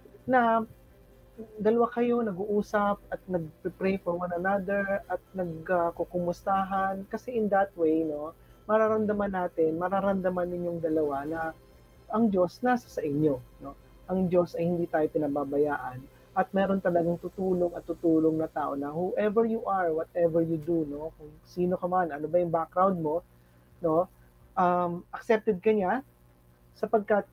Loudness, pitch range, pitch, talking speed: -29 LUFS, 160-195 Hz, 175 Hz, 145 wpm